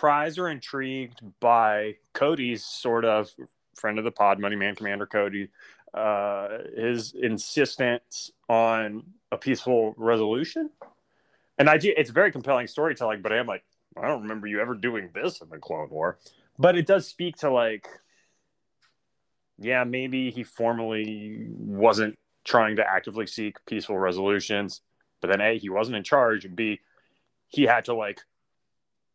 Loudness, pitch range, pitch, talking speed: -25 LUFS, 105-130 Hz, 115 Hz, 150 wpm